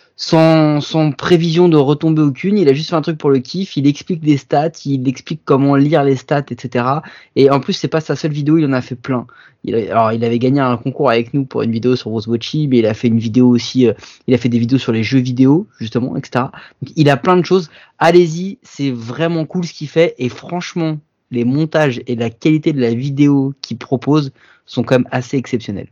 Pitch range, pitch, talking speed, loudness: 125-160 Hz, 140 Hz, 240 wpm, -15 LUFS